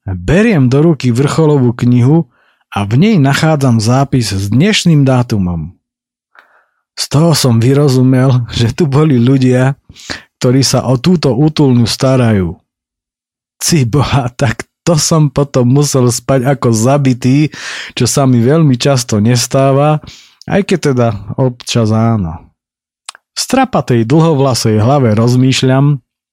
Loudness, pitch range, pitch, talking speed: -11 LUFS, 120-145 Hz, 130 Hz, 120 wpm